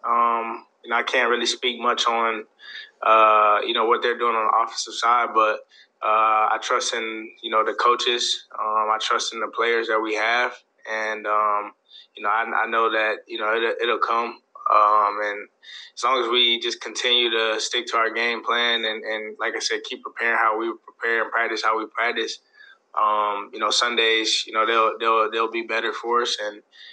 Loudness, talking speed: -21 LUFS, 205 wpm